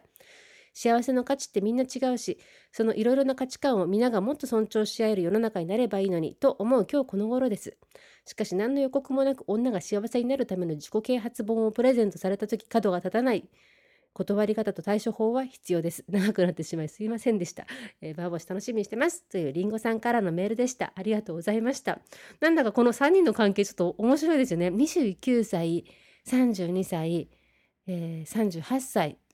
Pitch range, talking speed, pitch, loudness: 190-260 Hz, 400 characters per minute, 225 Hz, -27 LUFS